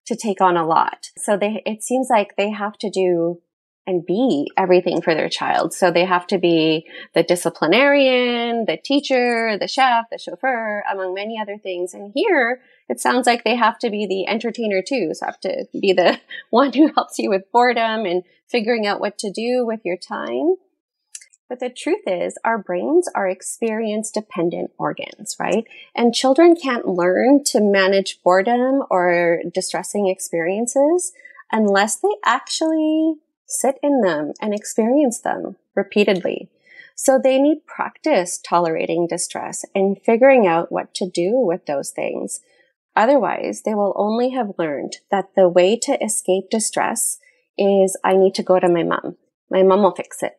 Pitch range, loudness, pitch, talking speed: 185-260 Hz, -19 LUFS, 215 Hz, 165 wpm